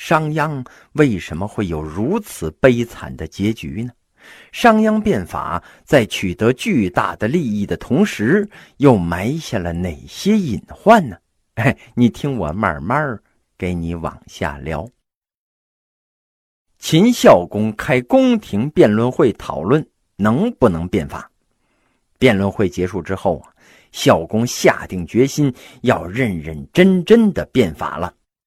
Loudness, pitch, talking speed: -17 LUFS, 115 Hz, 190 characters per minute